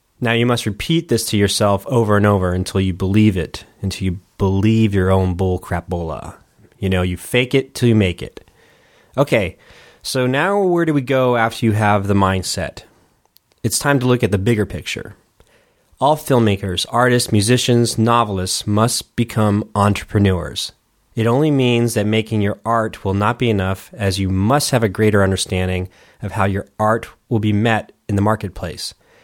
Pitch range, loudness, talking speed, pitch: 95-120 Hz, -17 LUFS, 180 wpm, 105 Hz